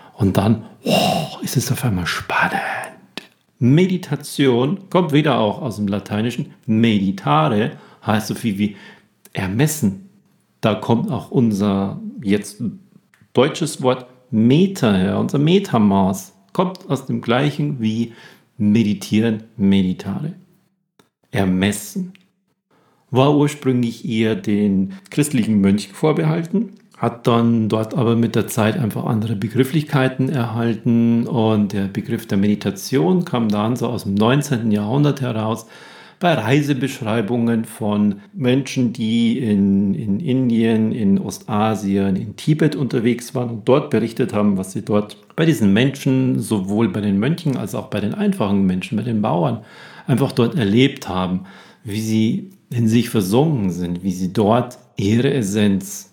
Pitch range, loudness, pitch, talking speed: 105-145 Hz, -19 LUFS, 115 Hz, 130 wpm